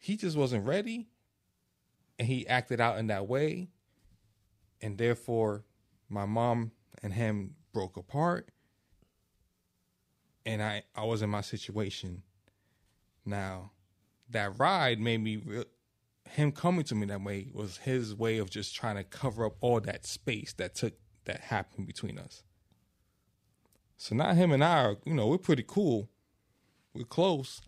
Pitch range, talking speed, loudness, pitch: 100-125 Hz, 150 wpm, -32 LUFS, 110 Hz